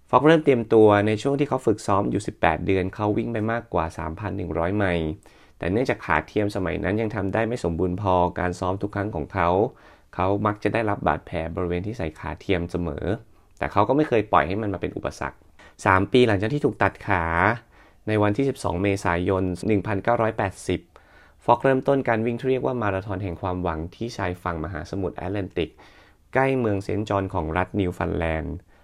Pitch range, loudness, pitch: 90-110 Hz, -24 LUFS, 100 Hz